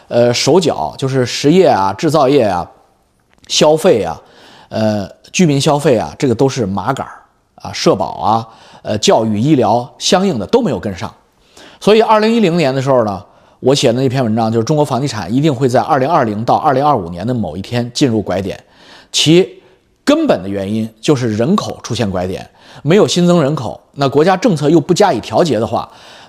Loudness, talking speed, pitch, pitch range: -13 LUFS, 285 characters per minute, 130 Hz, 110-155 Hz